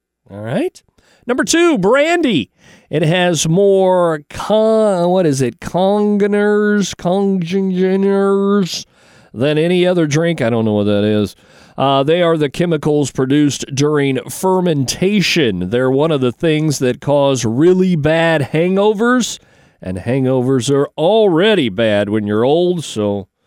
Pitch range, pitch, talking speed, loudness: 130-195 Hz, 165 Hz, 130 wpm, -14 LUFS